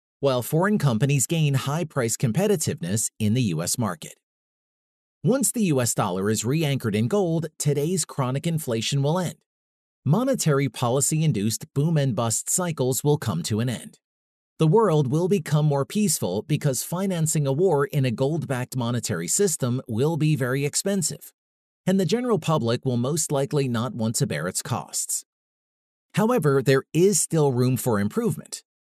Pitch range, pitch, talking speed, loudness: 125-160 Hz, 140 Hz, 160 wpm, -23 LUFS